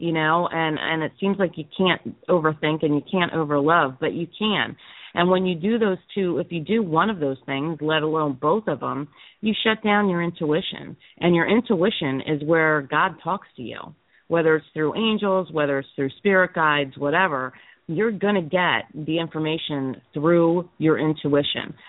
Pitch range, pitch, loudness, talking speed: 155-185 Hz, 165 Hz, -22 LUFS, 185 wpm